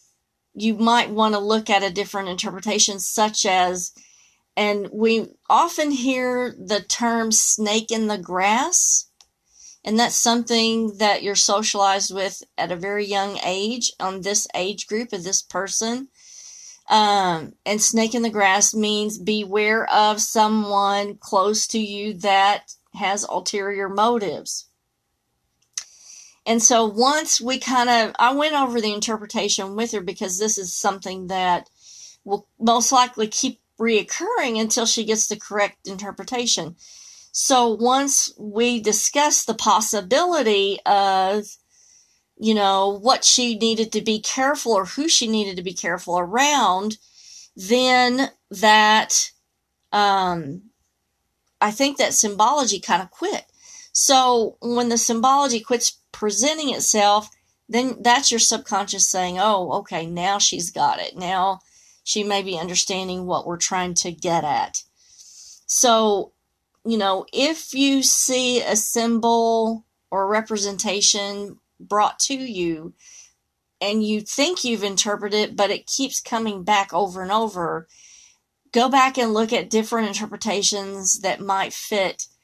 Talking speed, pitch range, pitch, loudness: 135 wpm, 195-235 Hz, 215 Hz, -20 LUFS